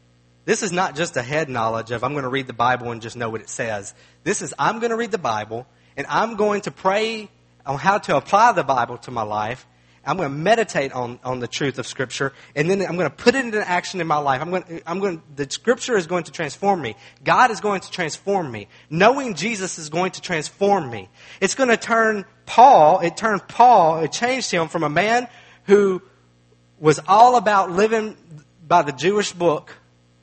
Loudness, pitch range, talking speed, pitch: -20 LUFS, 130-200 Hz, 225 wpm, 170 Hz